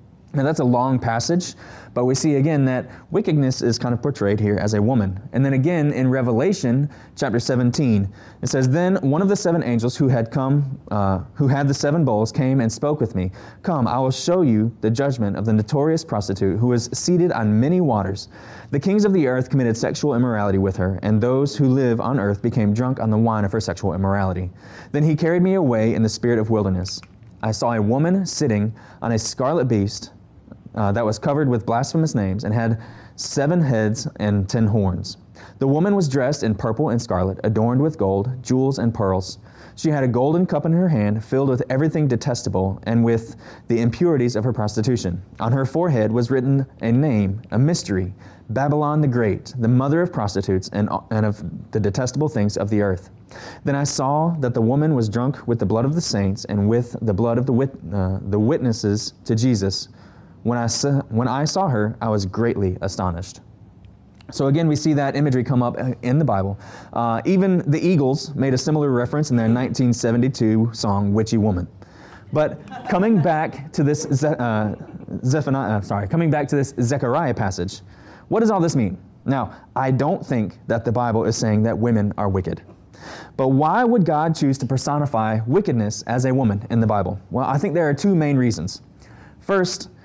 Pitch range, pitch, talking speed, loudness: 105-140 Hz, 120 Hz, 200 wpm, -20 LUFS